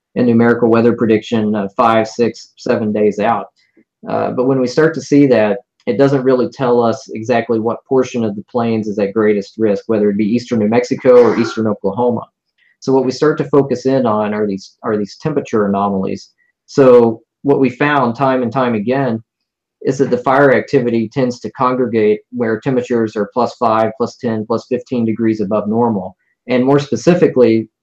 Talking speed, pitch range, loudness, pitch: 190 wpm, 110-130 Hz, -14 LUFS, 120 Hz